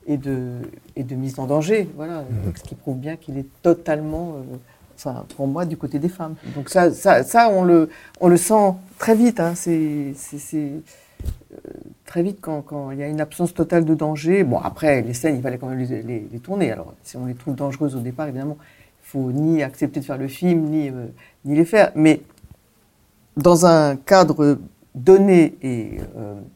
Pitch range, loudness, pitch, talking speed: 135-170 Hz, -19 LUFS, 150 Hz, 210 wpm